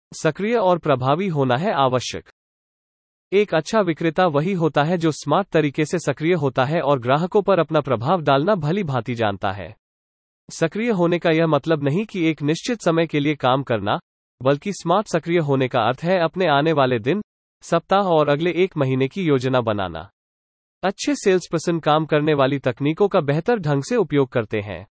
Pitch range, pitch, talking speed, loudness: 130-180 Hz, 155 Hz, 185 wpm, -20 LUFS